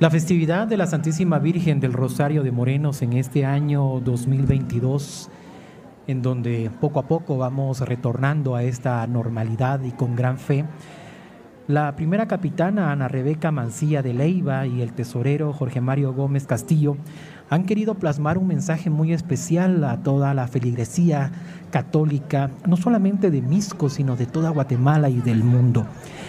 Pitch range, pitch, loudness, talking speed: 130-160 Hz, 145 Hz, -22 LUFS, 150 wpm